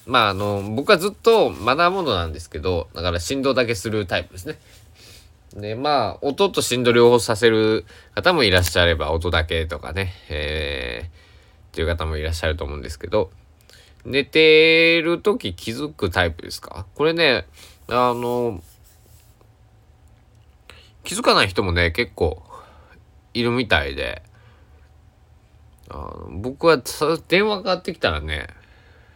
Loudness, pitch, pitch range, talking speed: -20 LUFS, 100 Hz, 85-125 Hz, 270 characters per minute